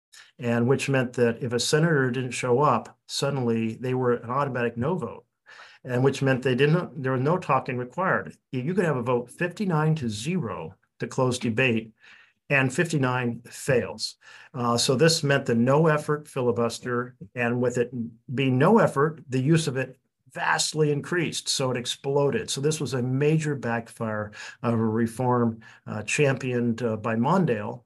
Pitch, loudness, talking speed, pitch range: 130 Hz, -25 LUFS, 170 wpm, 120-145 Hz